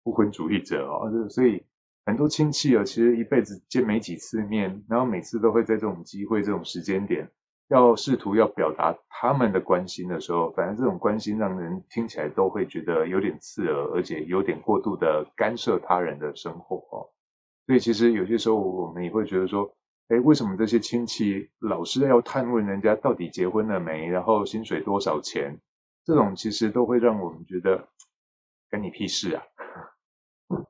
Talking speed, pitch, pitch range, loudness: 285 characters per minute, 110 Hz, 95-120 Hz, -25 LUFS